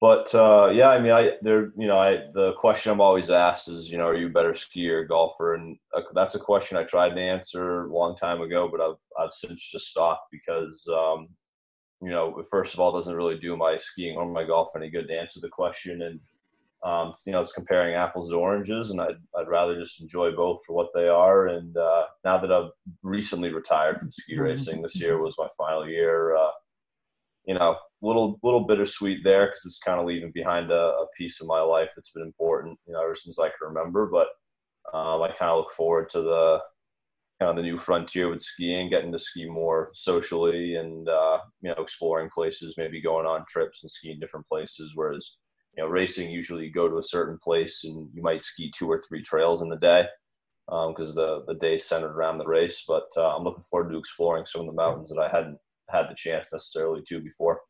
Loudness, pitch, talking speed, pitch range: -25 LUFS, 85 Hz, 225 wpm, 80-95 Hz